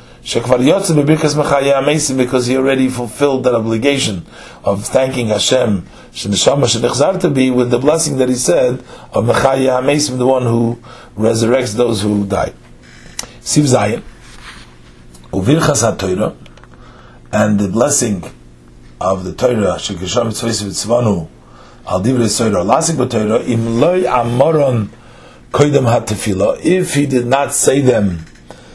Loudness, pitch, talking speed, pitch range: -14 LUFS, 120 Hz, 125 wpm, 100-135 Hz